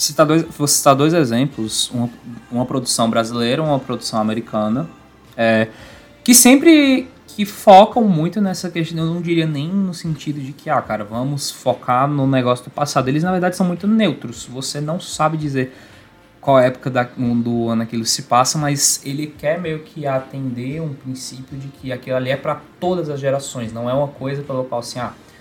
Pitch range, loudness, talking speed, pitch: 125-160 Hz, -17 LUFS, 190 wpm, 140 Hz